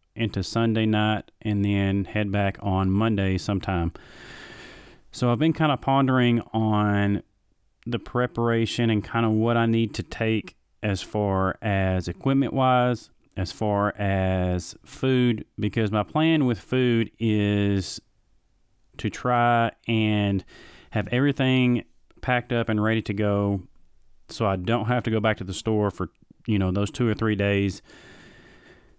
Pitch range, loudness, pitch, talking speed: 100-120 Hz, -24 LUFS, 110 Hz, 145 wpm